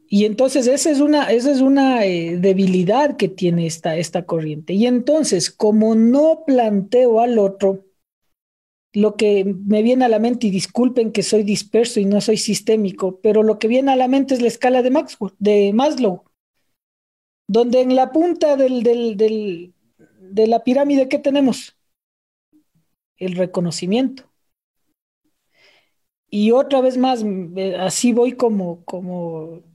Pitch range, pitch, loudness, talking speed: 195-255 Hz, 220 Hz, -17 LUFS, 150 wpm